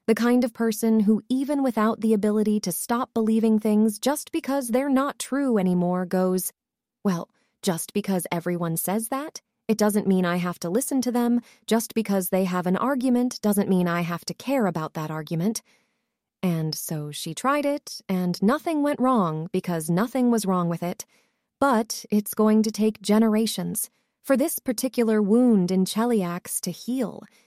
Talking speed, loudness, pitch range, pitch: 175 wpm, -24 LUFS, 185-245 Hz, 220 Hz